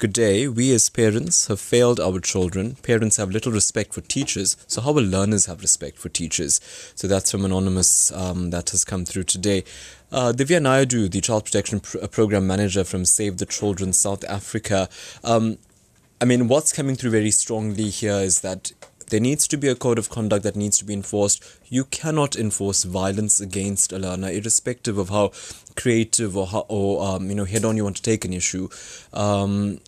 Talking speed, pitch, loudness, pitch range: 195 wpm, 105 Hz, -21 LUFS, 95-115 Hz